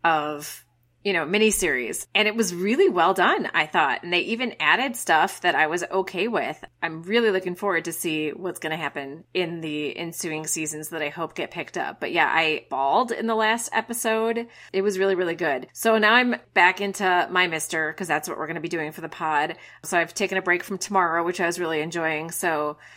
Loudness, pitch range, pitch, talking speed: -23 LUFS, 160-205 Hz, 175 Hz, 225 wpm